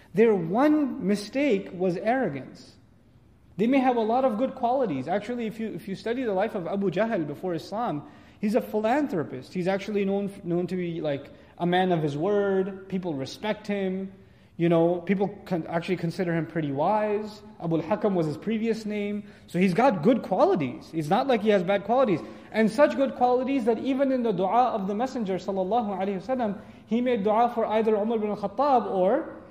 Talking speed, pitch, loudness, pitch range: 190 wpm, 205 Hz, -26 LUFS, 180-235 Hz